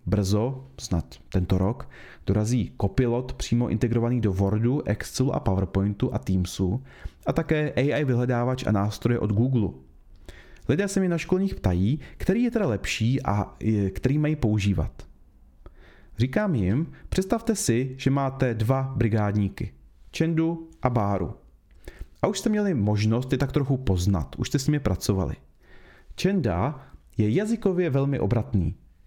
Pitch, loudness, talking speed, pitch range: 115 Hz, -25 LUFS, 140 wpm, 95-135 Hz